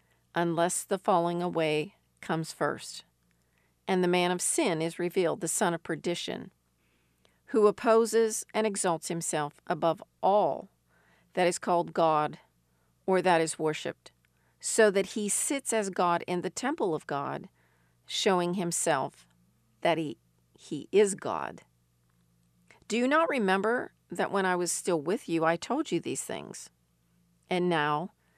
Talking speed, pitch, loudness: 145 wpm, 170 Hz, -29 LUFS